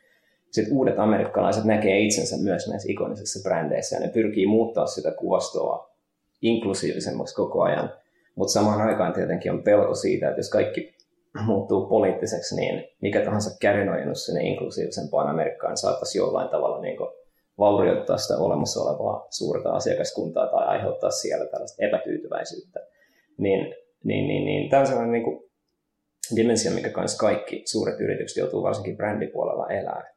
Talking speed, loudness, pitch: 140 wpm, -24 LUFS, 345 Hz